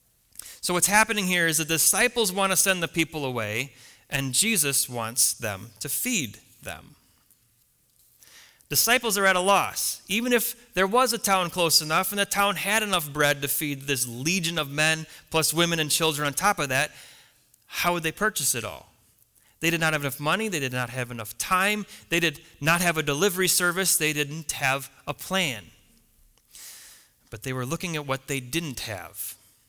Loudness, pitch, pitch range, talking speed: -24 LUFS, 160 Hz, 135-190 Hz, 185 wpm